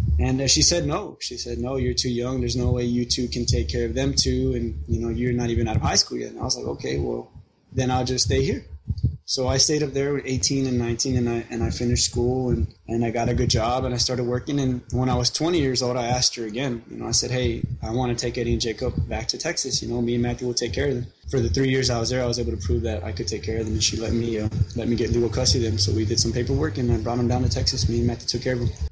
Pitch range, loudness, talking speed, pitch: 115-125 Hz, -23 LUFS, 320 wpm, 120 Hz